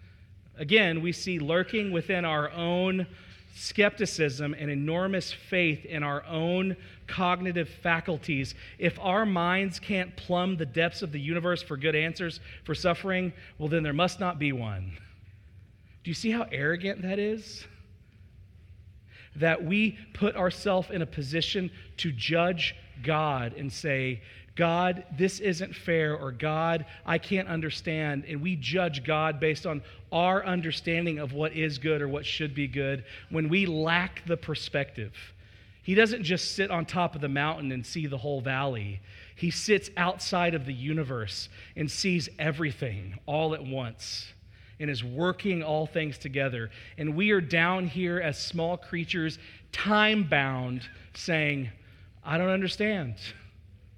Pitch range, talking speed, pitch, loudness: 130-180 Hz, 150 wpm, 155 Hz, -29 LUFS